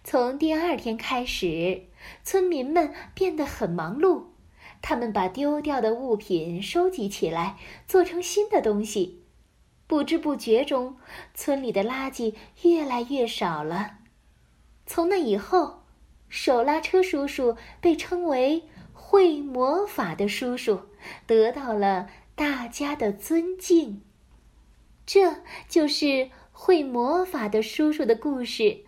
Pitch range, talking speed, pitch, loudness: 220-335 Hz, 175 characters per minute, 270 Hz, -25 LUFS